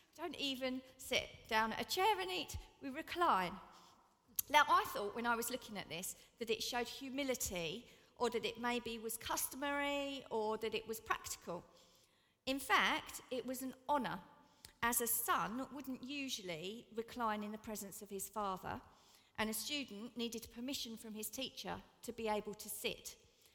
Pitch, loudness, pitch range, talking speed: 235 Hz, -40 LUFS, 220-270 Hz, 170 wpm